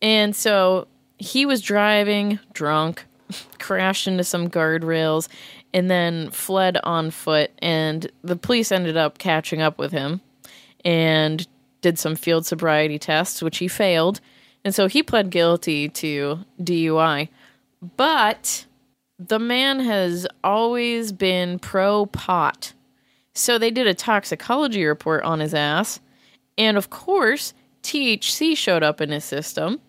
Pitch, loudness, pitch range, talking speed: 180 Hz, -21 LUFS, 160-210 Hz, 130 wpm